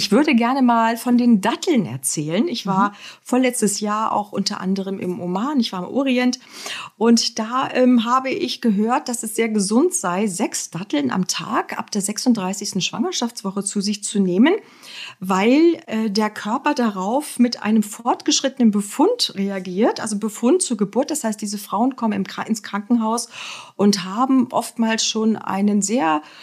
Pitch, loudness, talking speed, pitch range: 225 Hz, -20 LUFS, 165 wpm, 205-250 Hz